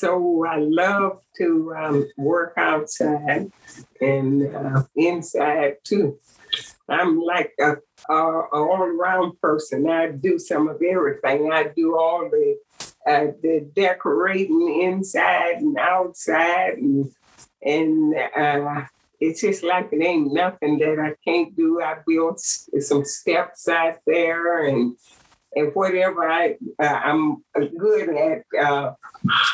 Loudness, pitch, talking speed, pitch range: -21 LUFS, 165 Hz, 125 wpm, 150-185 Hz